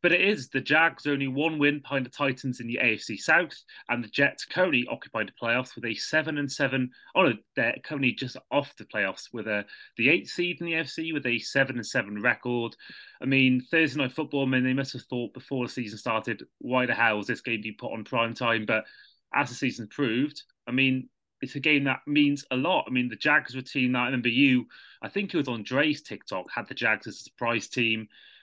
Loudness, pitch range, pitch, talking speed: -27 LUFS, 120-145 Hz, 130 Hz, 240 wpm